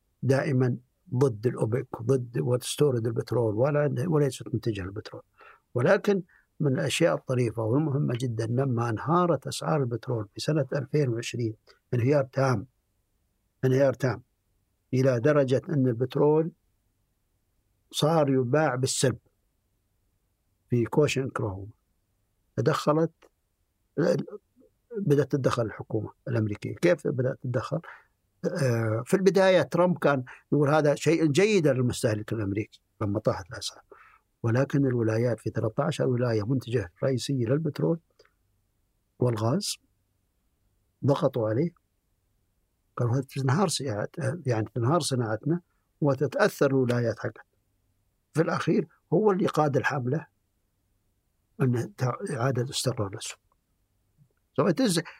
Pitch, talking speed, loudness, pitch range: 125 Hz, 95 wpm, -27 LUFS, 105-145 Hz